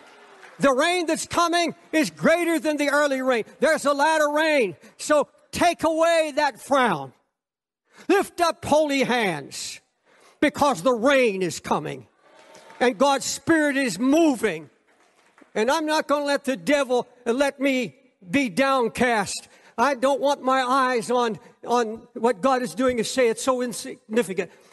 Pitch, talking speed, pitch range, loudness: 270 Hz, 150 wpm, 245-300 Hz, -22 LUFS